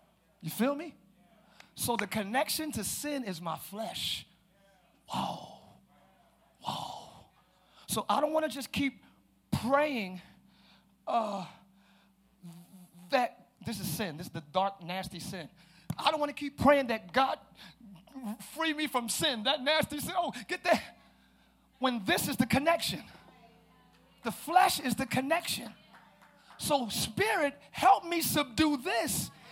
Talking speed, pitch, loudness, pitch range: 135 wpm, 230 Hz, -31 LUFS, 195-290 Hz